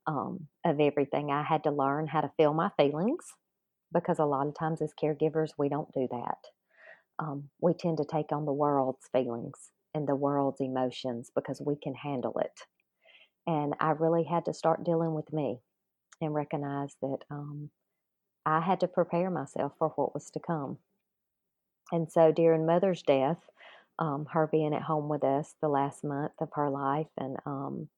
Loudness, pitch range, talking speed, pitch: -31 LUFS, 140-160 Hz, 180 wpm, 150 Hz